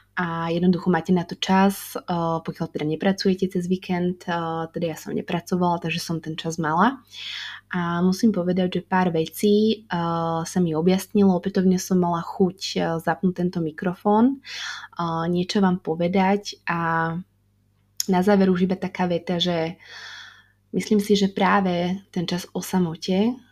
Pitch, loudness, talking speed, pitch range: 180 Hz, -23 LUFS, 140 wpm, 165-190 Hz